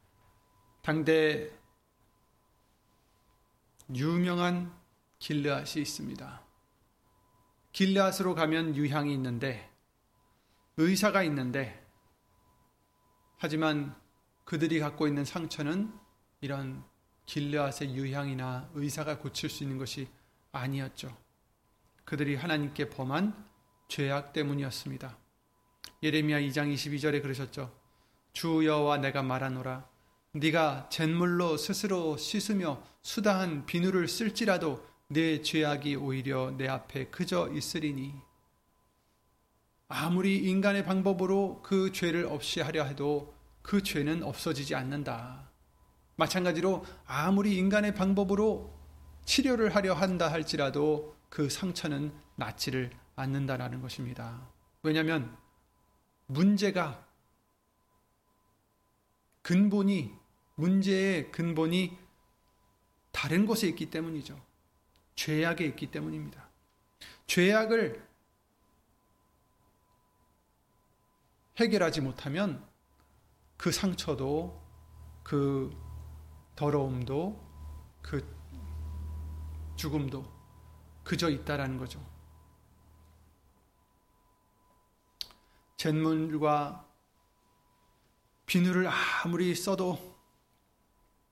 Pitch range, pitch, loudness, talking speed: 120-170 Hz, 145 Hz, -31 LUFS, 195 characters per minute